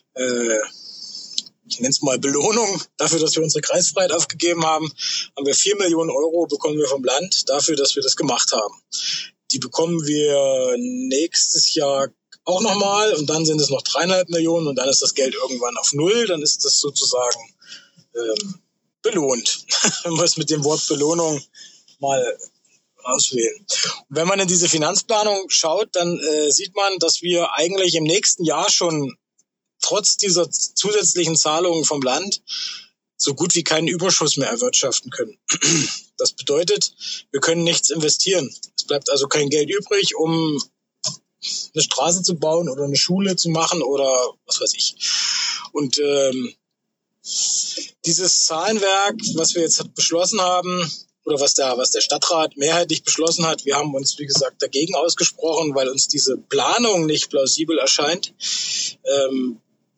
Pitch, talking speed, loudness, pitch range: 170 Hz, 155 wpm, -18 LUFS, 150-200 Hz